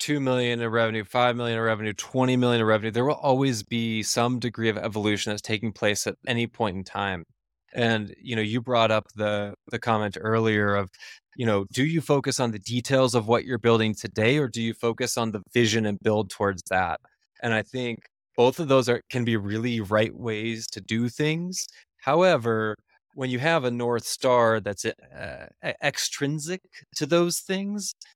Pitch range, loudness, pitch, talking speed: 110-125 Hz, -25 LUFS, 115 Hz, 195 wpm